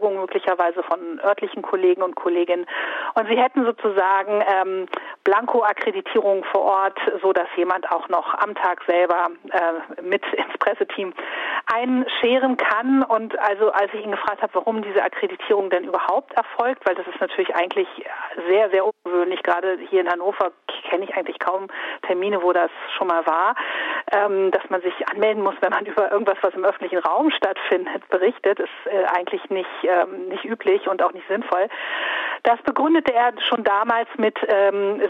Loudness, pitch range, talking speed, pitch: -21 LUFS, 185-230 Hz, 165 wpm, 200 Hz